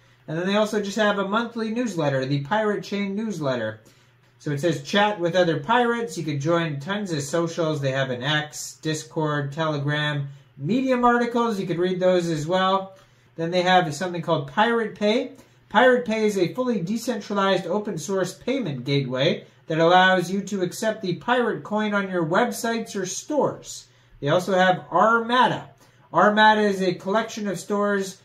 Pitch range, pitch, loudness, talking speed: 150-215 Hz, 185 Hz, -23 LUFS, 170 wpm